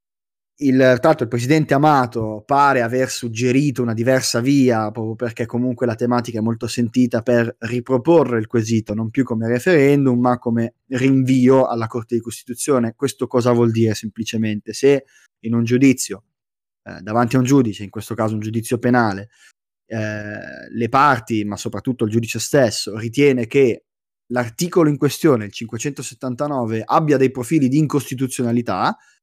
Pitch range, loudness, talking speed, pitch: 115-130 Hz, -18 LUFS, 150 wpm, 120 Hz